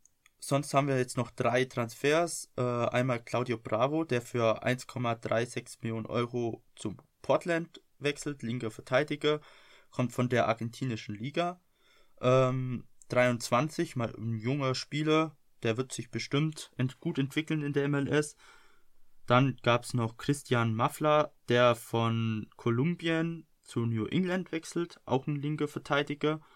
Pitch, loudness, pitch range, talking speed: 130 Hz, -31 LUFS, 120-150 Hz, 135 wpm